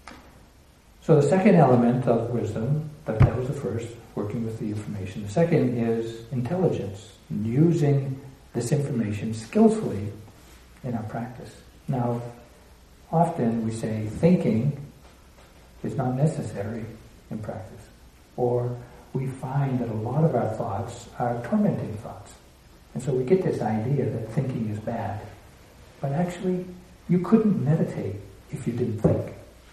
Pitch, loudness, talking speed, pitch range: 120 Hz, -25 LUFS, 135 wpm, 105-140 Hz